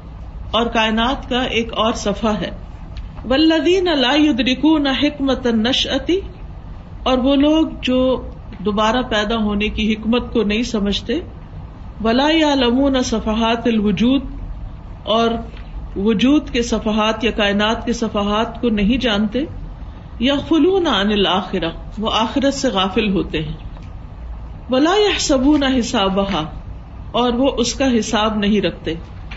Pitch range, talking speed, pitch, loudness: 205-260 Hz, 125 wpm, 225 Hz, -17 LUFS